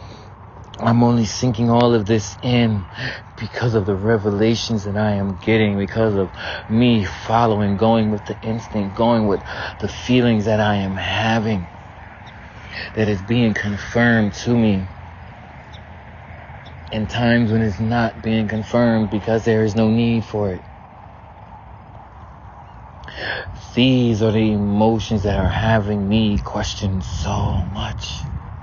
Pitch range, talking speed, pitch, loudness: 100-115 Hz, 130 wpm, 110 Hz, -19 LUFS